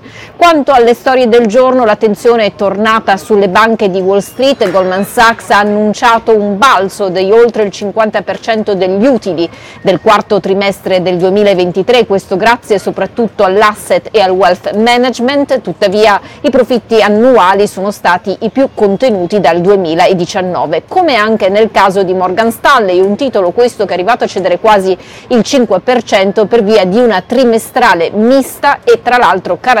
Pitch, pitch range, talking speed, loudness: 210 Hz, 195-240 Hz, 155 wpm, -9 LUFS